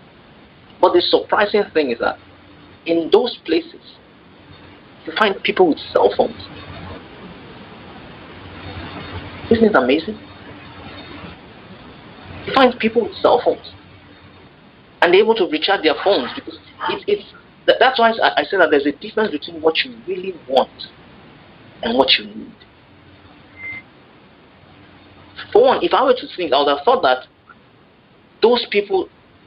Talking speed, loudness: 130 wpm, -17 LUFS